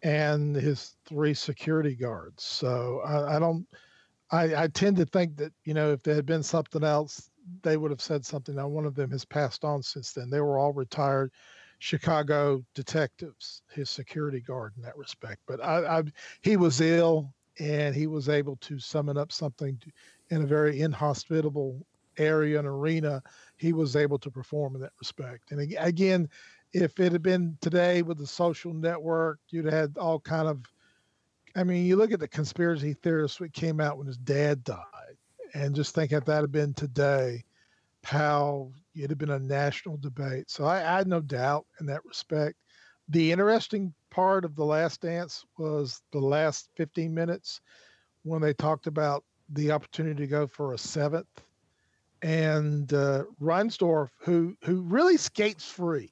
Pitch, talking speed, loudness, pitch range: 150 Hz, 175 wpm, -28 LUFS, 145-165 Hz